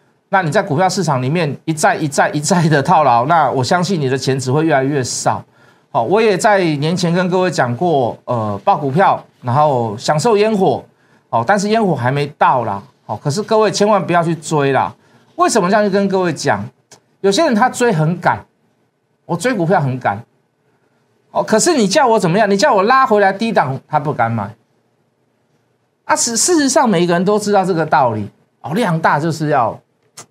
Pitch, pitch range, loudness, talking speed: 165 Hz, 140-200 Hz, -15 LUFS, 275 characters per minute